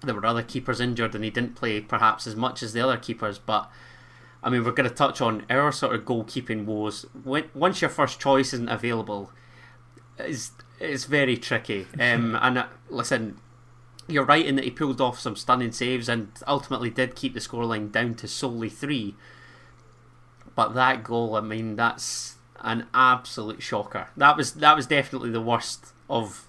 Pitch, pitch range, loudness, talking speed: 120 Hz, 115-130 Hz, -25 LUFS, 185 wpm